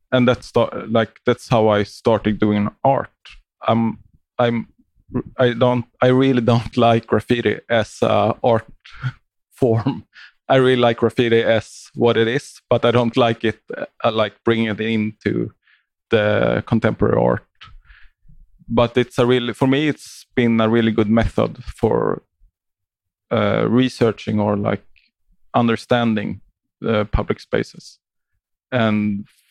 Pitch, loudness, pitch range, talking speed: 115 Hz, -19 LUFS, 105-125 Hz, 140 wpm